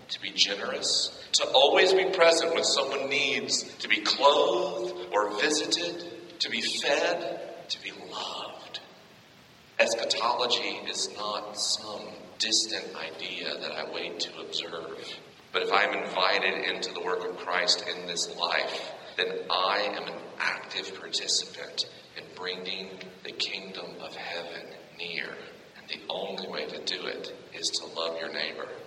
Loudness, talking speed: -28 LUFS, 145 wpm